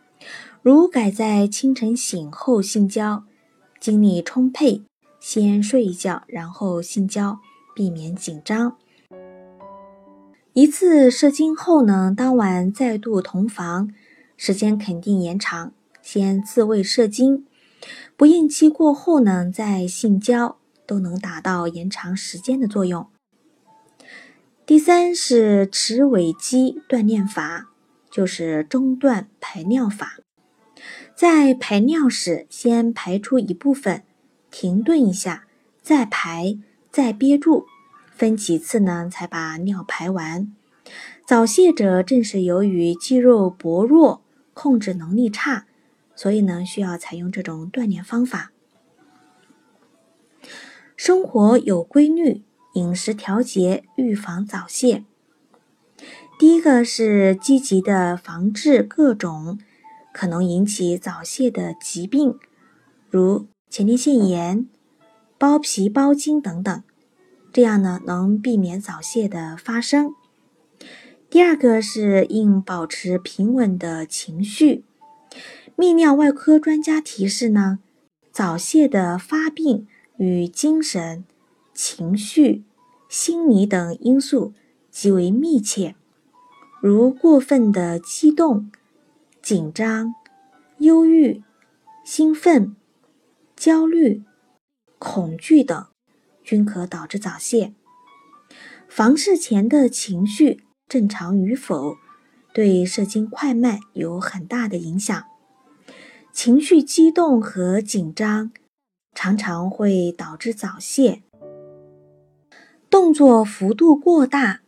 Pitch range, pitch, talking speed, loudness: 190-275 Hz, 220 Hz, 155 characters per minute, -18 LUFS